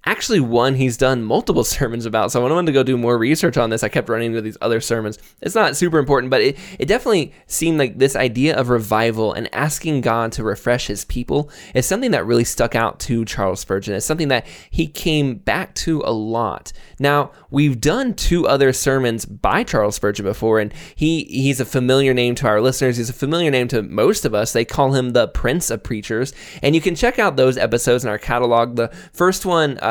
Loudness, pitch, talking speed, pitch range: -18 LUFS, 130 Hz, 225 wpm, 115-145 Hz